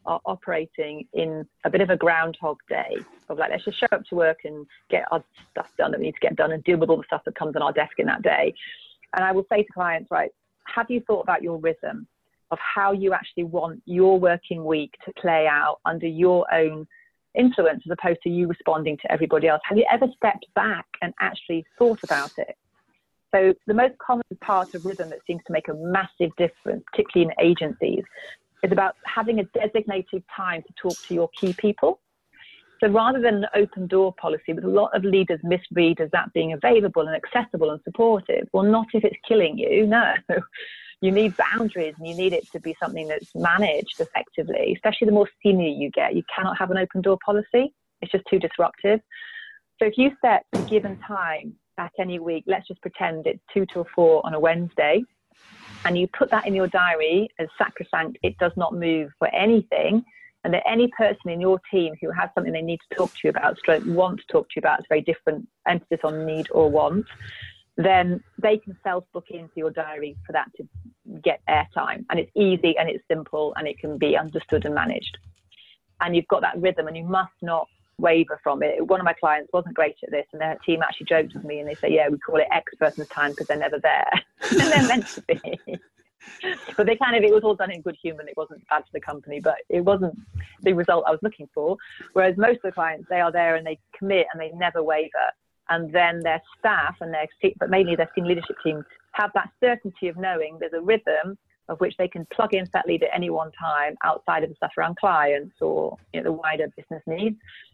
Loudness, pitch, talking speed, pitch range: -23 LUFS, 180 Hz, 225 wpm, 160-210 Hz